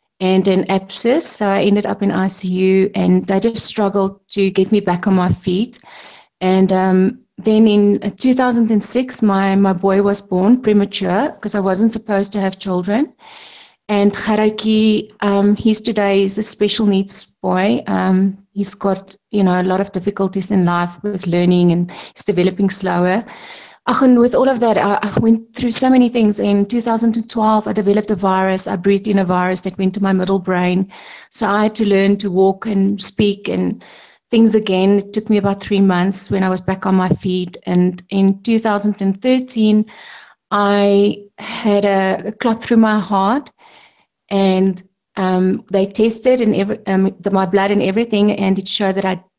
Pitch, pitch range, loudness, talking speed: 200 Hz, 190-215 Hz, -16 LUFS, 175 wpm